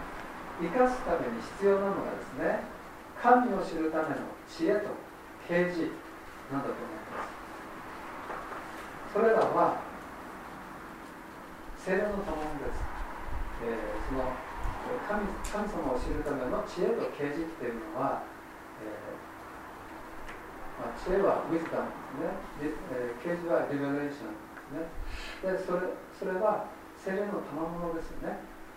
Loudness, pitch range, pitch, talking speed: -33 LUFS, 145-195 Hz, 170 Hz, 245 characters per minute